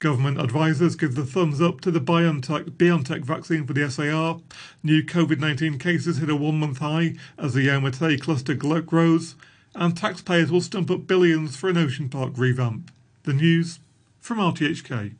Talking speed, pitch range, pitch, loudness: 175 wpm, 145-170 Hz, 155 Hz, -23 LUFS